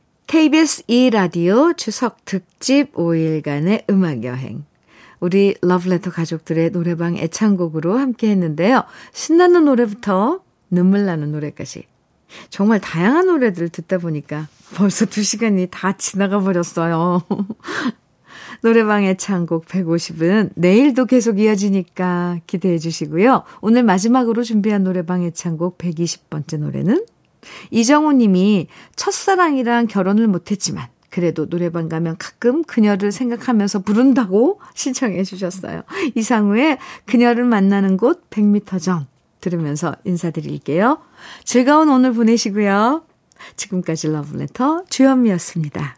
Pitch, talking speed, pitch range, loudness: 200 Hz, 290 characters per minute, 175-240 Hz, -17 LUFS